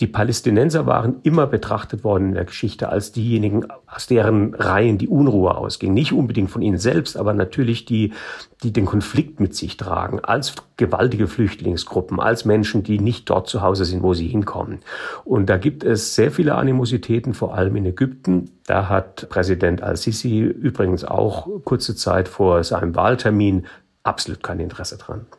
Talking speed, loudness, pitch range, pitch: 170 wpm, -20 LUFS, 95-120 Hz, 105 Hz